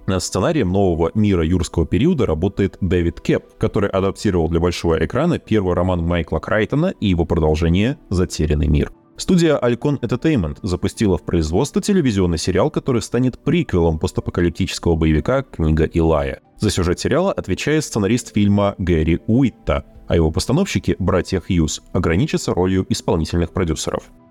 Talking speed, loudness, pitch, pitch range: 135 wpm, -19 LUFS, 95 Hz, 85-115 Hz